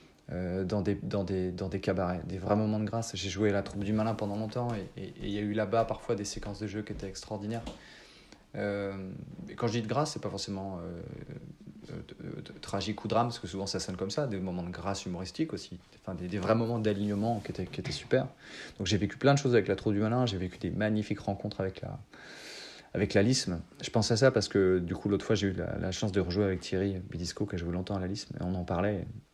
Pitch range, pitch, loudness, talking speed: 95-110 Hz, 100 Hz, -32 LUFS, 260 wpm